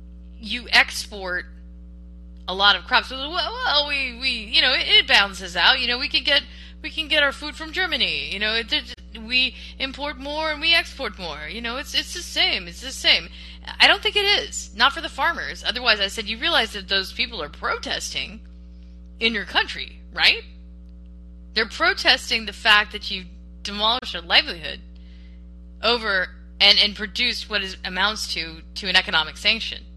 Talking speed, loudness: 185 wpm, -20 LUFS